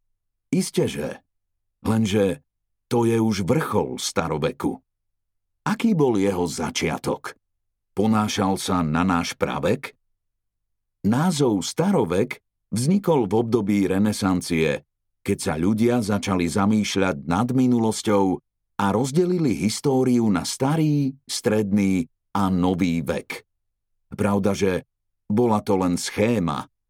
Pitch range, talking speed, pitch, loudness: 95-110 Hz, 100 wpm, 100 Hz, -22 LUFS